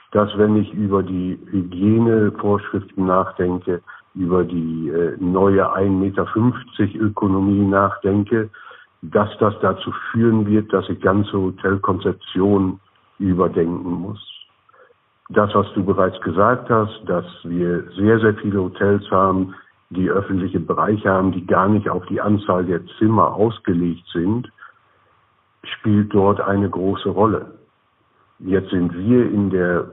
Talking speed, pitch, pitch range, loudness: 125 wpm, 100 Hz, 90-105 Hz, -19 LUFS